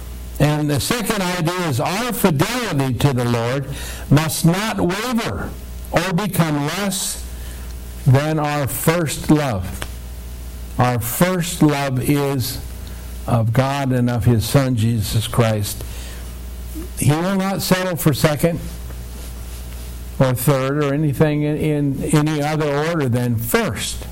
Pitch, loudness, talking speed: 135 Hz, -19 LUFS, 120 wpm